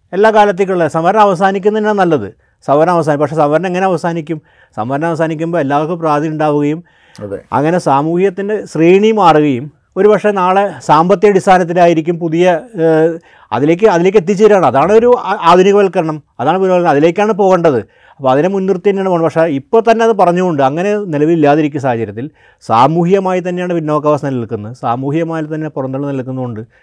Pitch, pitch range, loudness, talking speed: 170 Hz, 150-195 Hz, -12 LUFS, 125 wpm